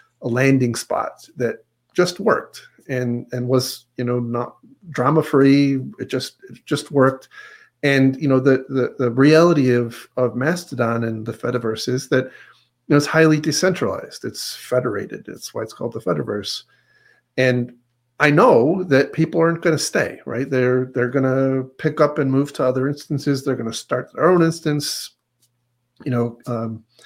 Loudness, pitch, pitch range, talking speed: -19 LUFS, 130 Hz, 125-150 Hz, 175 wpm